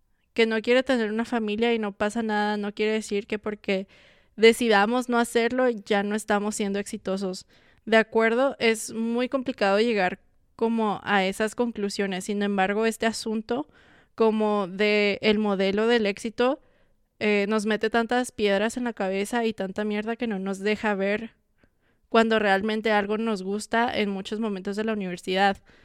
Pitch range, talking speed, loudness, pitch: 200-230 Hz, 165 wpm, -25 LUFS, 215 Hz